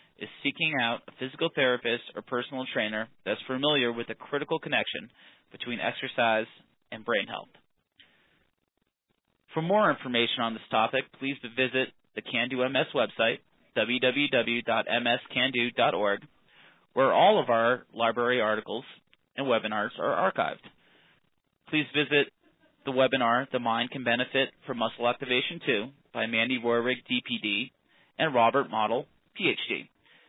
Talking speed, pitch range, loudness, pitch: 125 wpm, 115-135 Hz, -28 LUFS, 125 Hz